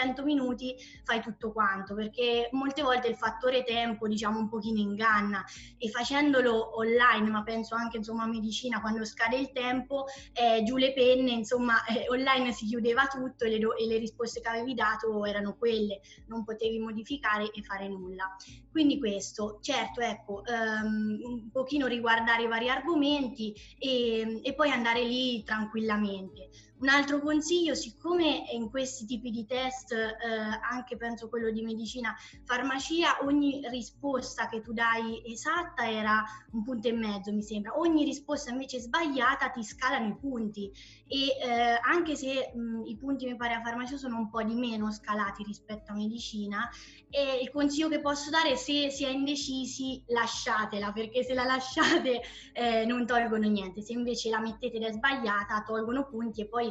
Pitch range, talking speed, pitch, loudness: 220-260 Hz, 165 wpm, 235 Hz, -30 LUFS